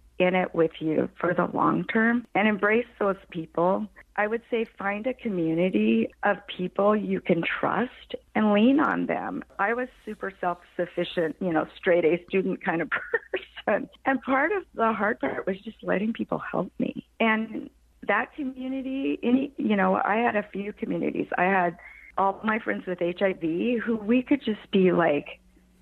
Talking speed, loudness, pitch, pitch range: 175 wpm, -26 LUFS, 205 Hz, 180-235 Hz